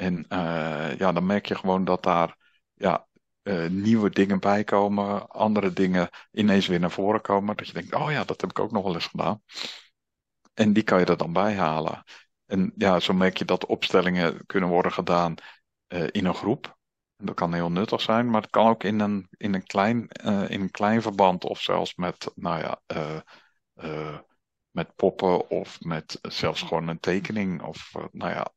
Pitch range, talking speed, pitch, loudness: 85-105 Hz, 200 wpm, 95 Hz, -25 LUFS